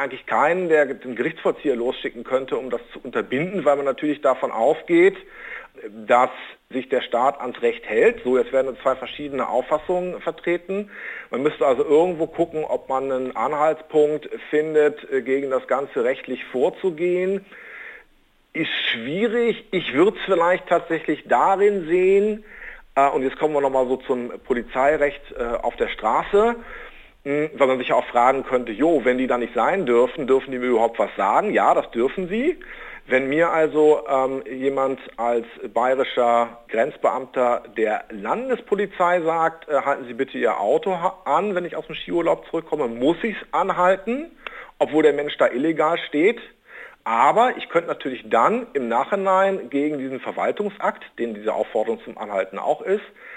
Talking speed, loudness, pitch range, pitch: 160 wpm, -21 LUFS, 135-195 Hz, 155 Hz